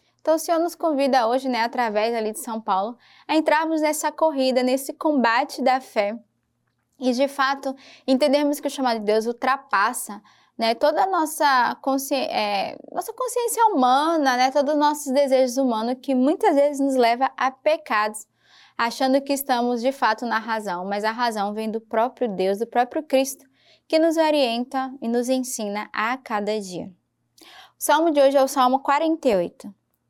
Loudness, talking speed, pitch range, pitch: -22 LUFS, 170 wpm, 230-290 Hz, 260 Hz